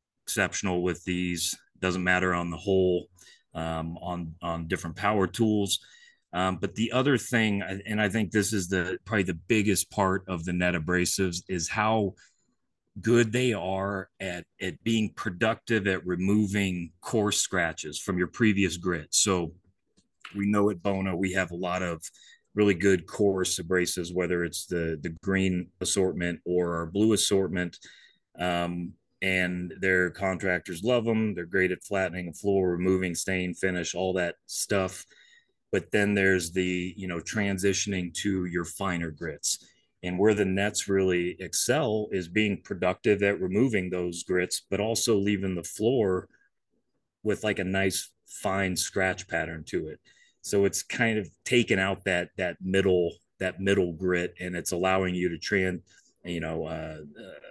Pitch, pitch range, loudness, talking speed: 95 Hz, 90-100 Hz, -28 LUFS, 160 wpm